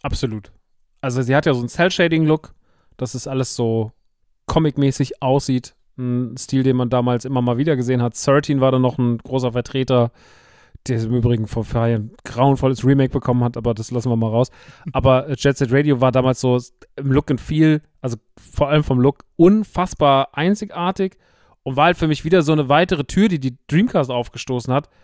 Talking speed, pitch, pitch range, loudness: 190 wpm, 130 Hz, 120-145 Hz, -19 LUFS